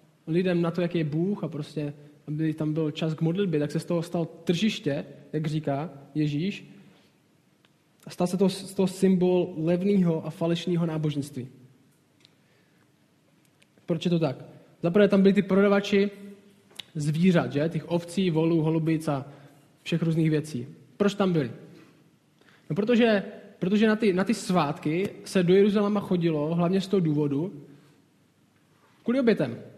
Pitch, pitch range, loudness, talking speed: 165 Hz, 155-190 Hz, -26 LUFS, 145 wpm